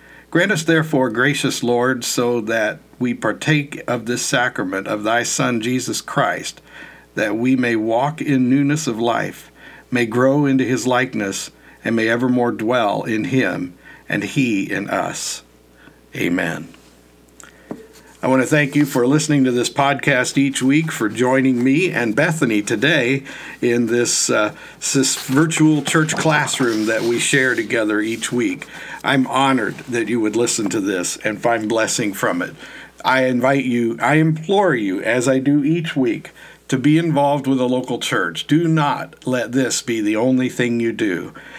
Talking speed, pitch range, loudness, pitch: 165 wpm, 120-145 Hz, -18 LUFS, 130 Hz